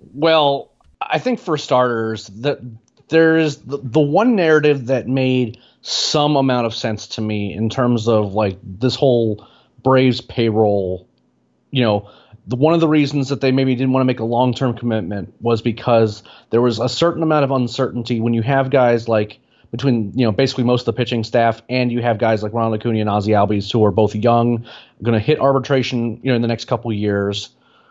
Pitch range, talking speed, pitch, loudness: 110-135 Hz, 200 wpm, 120 Hz, -17 LUFS